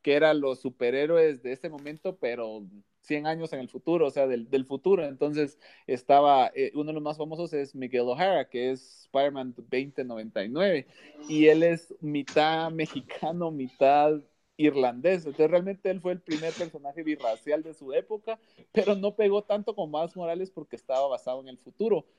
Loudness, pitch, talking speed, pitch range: -27 LUFS, 150 Hz, 175 wpm, 135-170 Hz